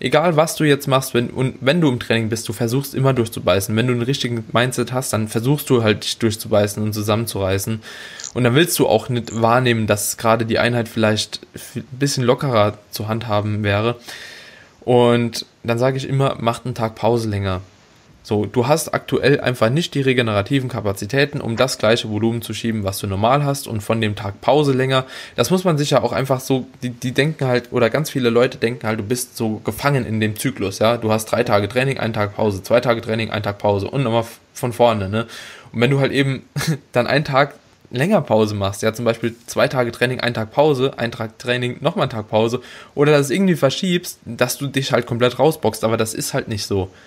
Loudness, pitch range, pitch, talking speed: -19 LUFS, 110-135 Hz, 120 Hz, 220 wpm